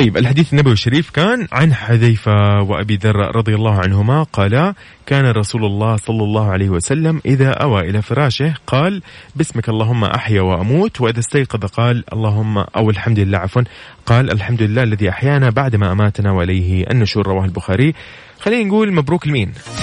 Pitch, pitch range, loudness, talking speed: 115 Hz, 105-135 Hz, -15 LUFS, 155 wpm